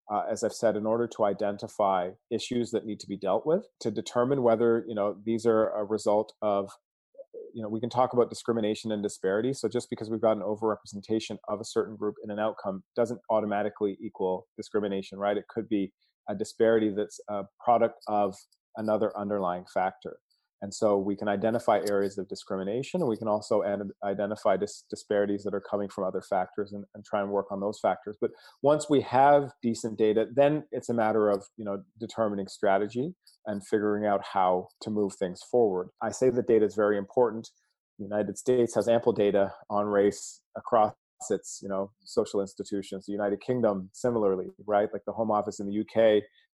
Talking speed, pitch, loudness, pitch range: 195 wpm, 105 Hz, -29 LUFS, 100-115 Hz